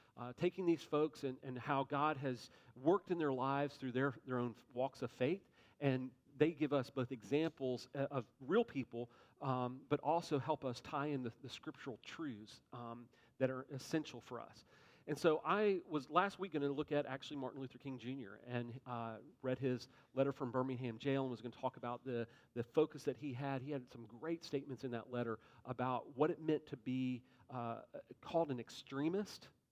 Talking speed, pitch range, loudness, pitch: 200 wpm, 125-145 Hz, -41 LUFS, 130 Hz